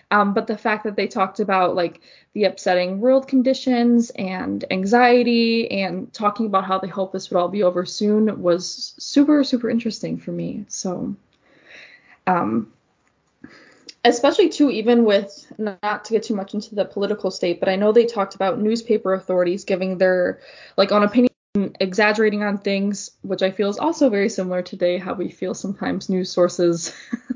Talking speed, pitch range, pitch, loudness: 175 wpm, 190-230 Hz, 205 Hz, -20 LUFS